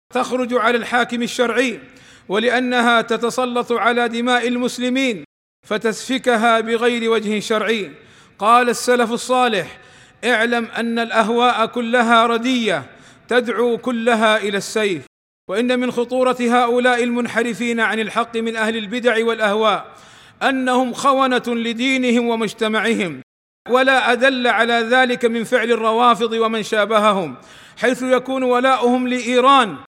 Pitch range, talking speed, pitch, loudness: 225-245 Hz, 105 wpm, 235 Hz, -17 LUFS